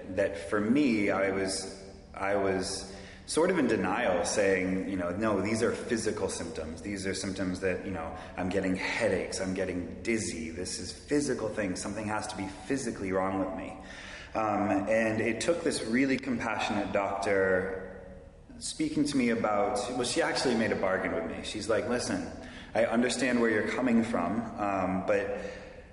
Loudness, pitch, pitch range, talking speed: -30 LUFS, 95 Hz, 95-110 Hz, 170 wpm